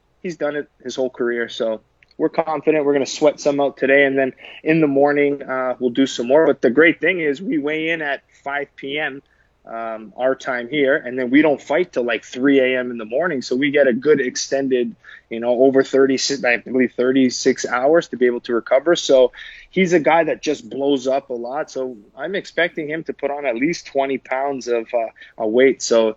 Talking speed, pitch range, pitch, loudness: 220 wpm, 125-145 Hz, 135 Hz, -19 LUFS